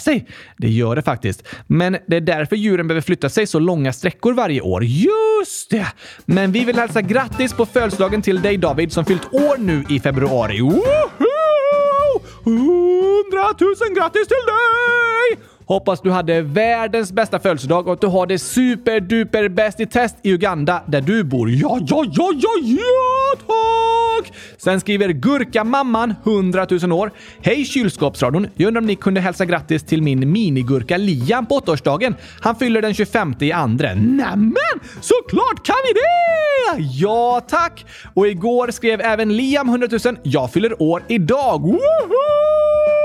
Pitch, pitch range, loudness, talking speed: 220 Hz, 175-275 Hz, -17 LUFS, 160 wpm